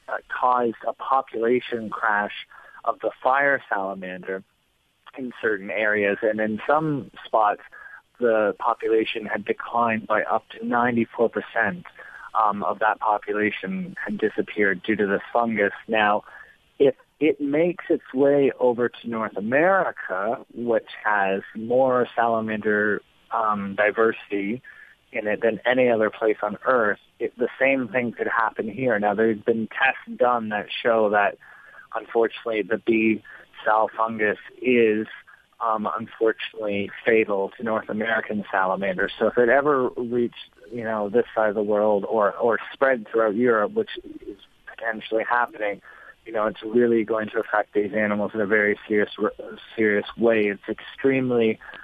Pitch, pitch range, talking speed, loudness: 110 Hz, 105-120 Hz, 140 wpm, -23 LUFS